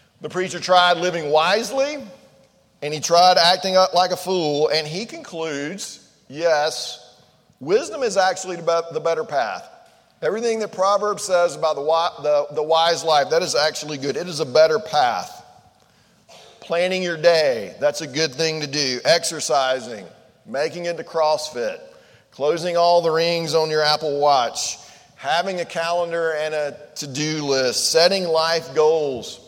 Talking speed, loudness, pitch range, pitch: 145 wpm, -20 LUFS, 150-180 Hz, 165 Hz